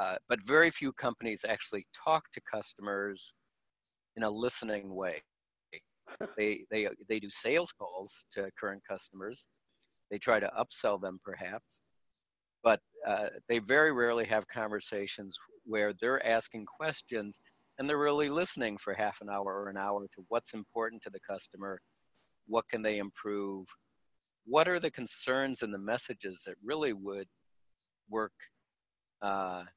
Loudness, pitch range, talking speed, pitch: -34 LUFS, 100-120 Hz, 150 wpm, 110 Hz